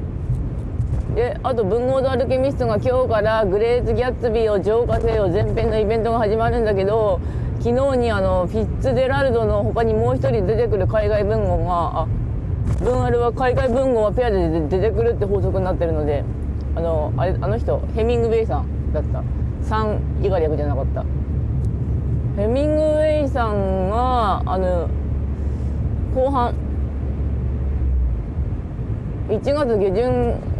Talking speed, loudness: 295 characters per minute, -20 LUFS